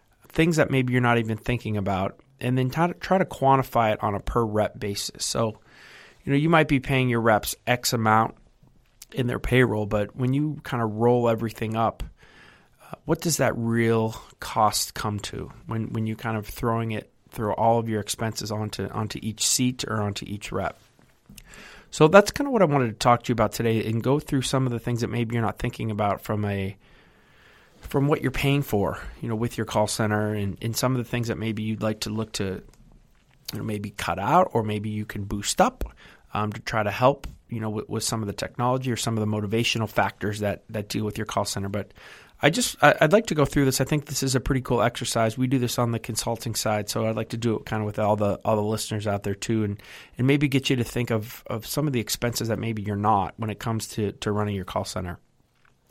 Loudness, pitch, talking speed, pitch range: -25 LUFS, 115 Hz, 245 wpm, 105-125 Hz